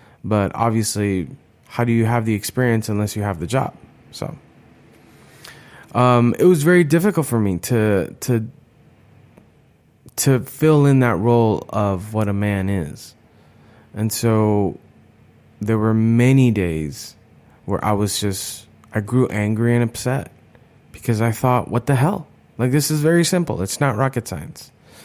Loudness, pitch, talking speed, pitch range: -19 LUFS, 115 Hz, 150 wpm, 105-130 Hz